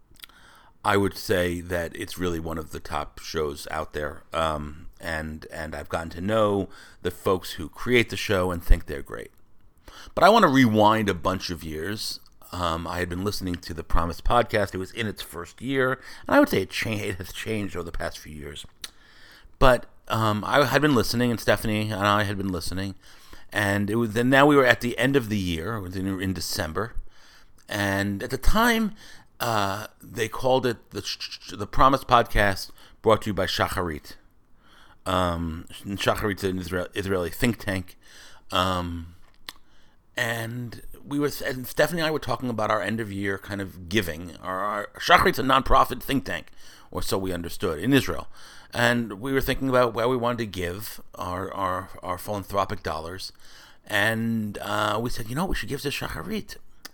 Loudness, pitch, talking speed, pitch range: -25 LUFS, 100 Hz, 185 wpm, 90-120 Hz